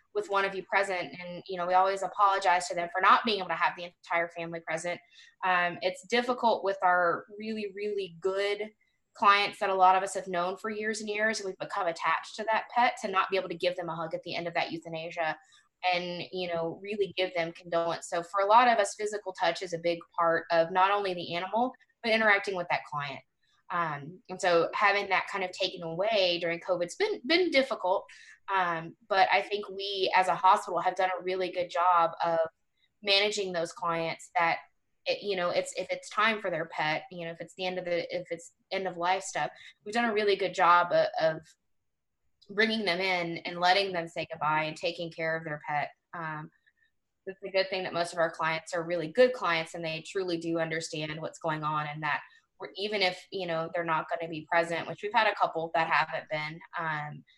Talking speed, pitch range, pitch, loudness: 225 wpm, 170-200 Hz, 180 Hz, -29 LUFS